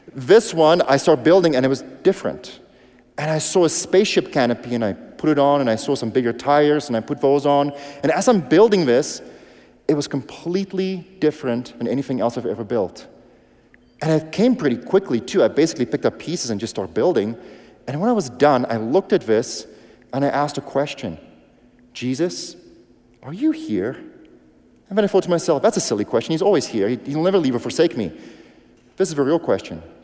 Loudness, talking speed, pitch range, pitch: -19 LUFS, 205 wpm, 125-175 Hz, 145 Hz